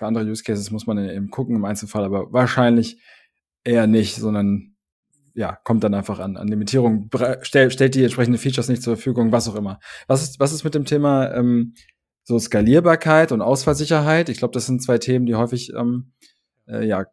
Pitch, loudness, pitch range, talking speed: 120 Hz, -19 LUFS, 105-130 Hz, 195 wpm